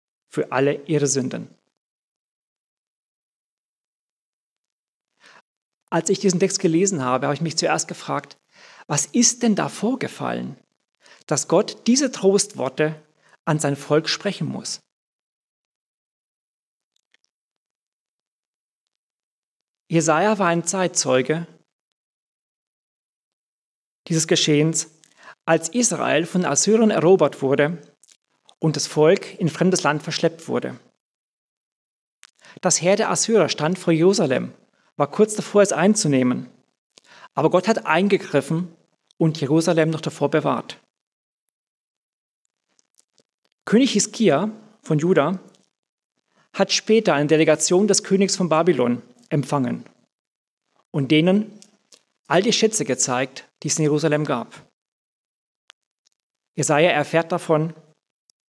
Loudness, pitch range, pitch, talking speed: -20 LUFS, 150-195 Hz, 165 Hz, 100 wpm